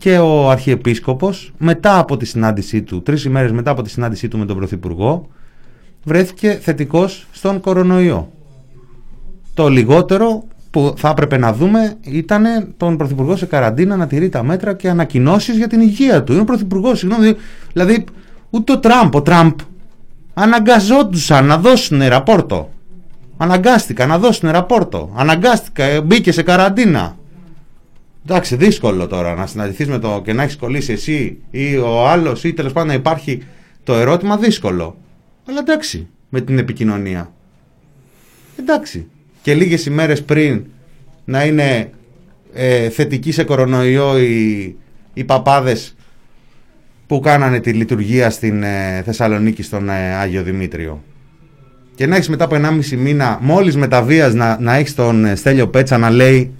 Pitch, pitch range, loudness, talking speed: 145 Hz, 125-180 Hz, -14 LUFS, 145 wpm